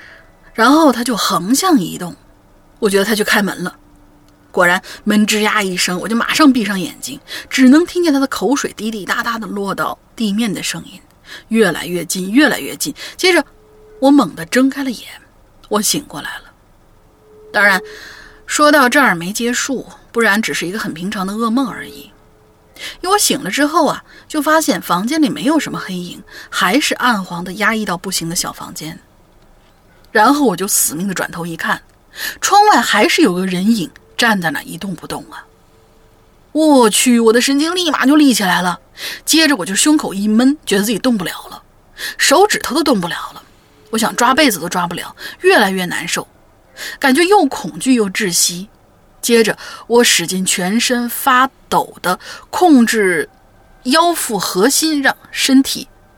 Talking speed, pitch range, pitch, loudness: 250 characters per minute, 195-290 Hz, 240 Hz, -14 LUFS